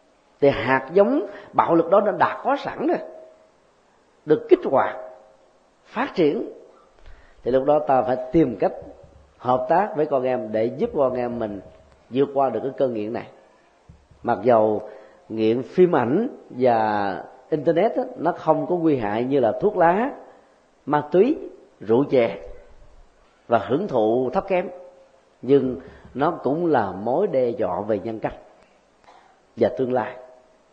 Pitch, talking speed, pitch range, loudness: 135 Hz, 155 wpm, 115-180 Hz, -22 LUFS